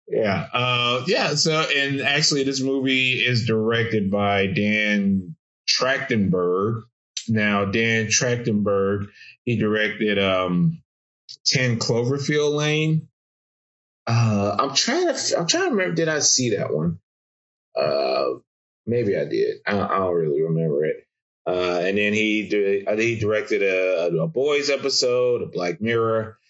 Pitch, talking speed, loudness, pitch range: 115 Hz, 135 wpm, -21 LUFS, 100-140 Hz